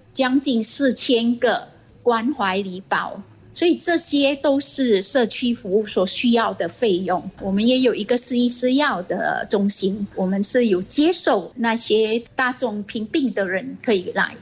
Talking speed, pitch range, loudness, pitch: 230 characters per minute, 200-265 Hz, -20 LUFS, 235 Hz